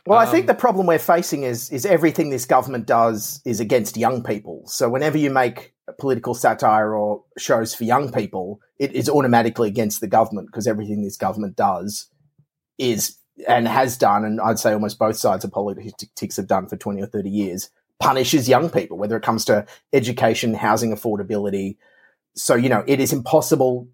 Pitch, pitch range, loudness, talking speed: 120 Hz, 105-145 Hz, -20 LUFS, 190 wpm